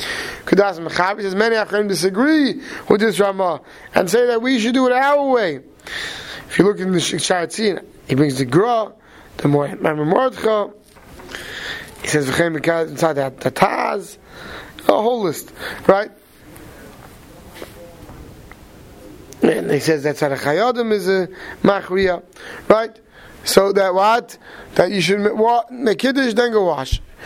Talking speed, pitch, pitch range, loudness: 150 wpm, 200 Hz, 170-230 Hz, -18 LUFS